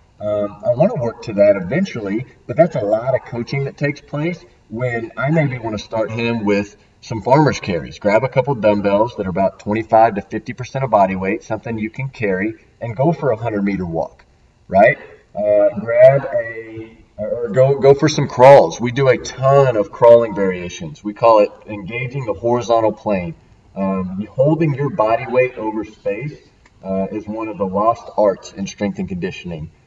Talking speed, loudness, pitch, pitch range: 190 wpm, -17 LUFS, 115 Hz, 105-140 Hz